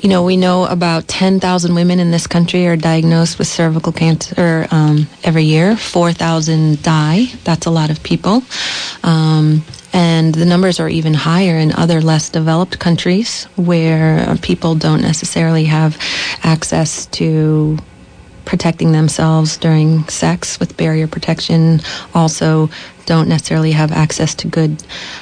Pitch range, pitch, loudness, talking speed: 155-175 Hz, 165 Hz, -13 LUFS, 140 wpm